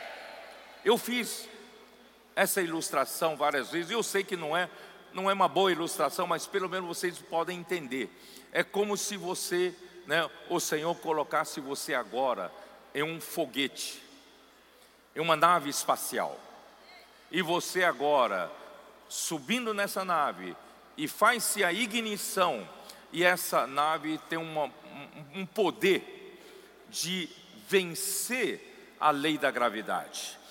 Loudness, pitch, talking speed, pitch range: -30 LUFS, 185 Hz, 125 wpm, 170-215 Hz